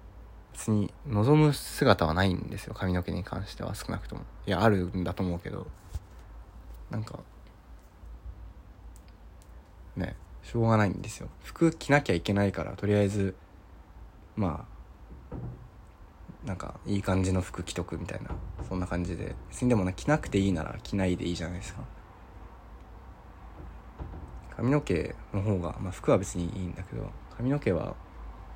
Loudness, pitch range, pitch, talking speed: -30 LUFS, 85-100 Hz, 90 Hz, 290 characters per minute